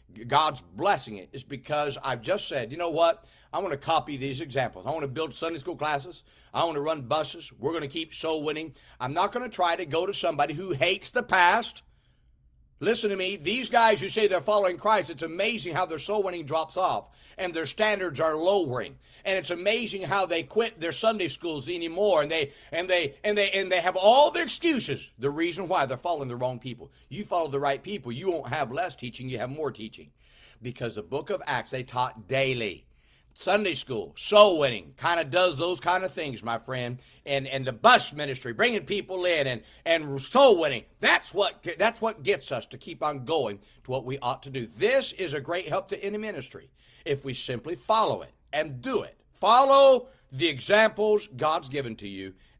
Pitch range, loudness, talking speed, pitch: 135-190 Hz, -26 LUFS, 215 wpm, 165 Hz